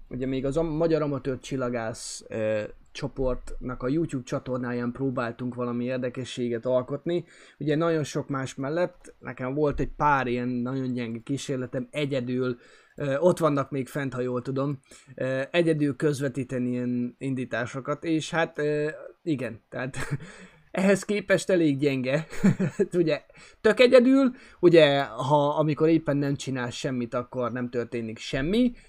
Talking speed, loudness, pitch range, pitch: 135 wpm, -26 LUFS, 125-155 Hz, 135 Hz